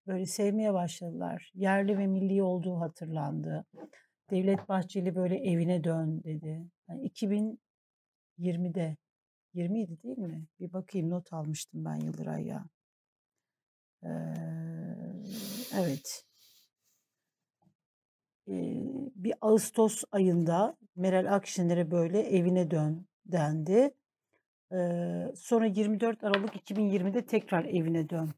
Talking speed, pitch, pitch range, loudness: 100 wpm, 185 Hz, 165-205 Hz, -32 LUFS